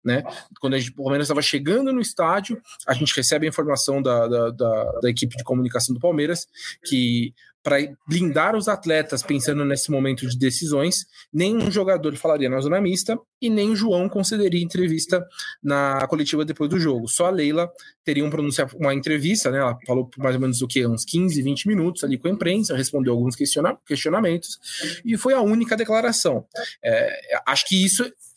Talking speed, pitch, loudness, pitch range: 185 wpm, 155 Hz, -21 LUFS, 135-190 Hz